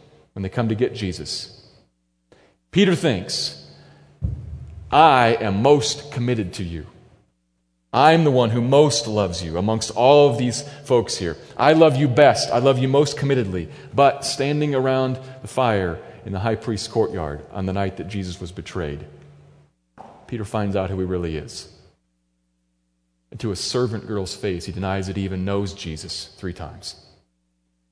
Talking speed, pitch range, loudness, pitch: 160 wpm, 85-130 Hz, -20 LUFS, 100 Hz